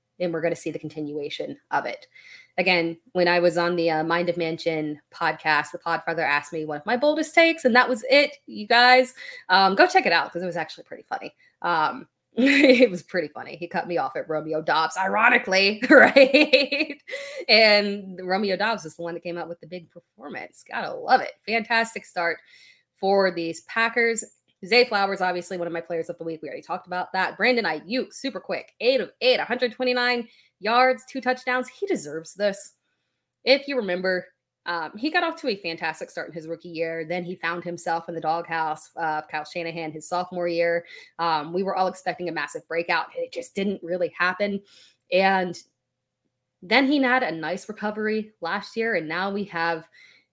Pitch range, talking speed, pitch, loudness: 165-245 Hz, 200 wpm, 185 Hz, -23 LUFS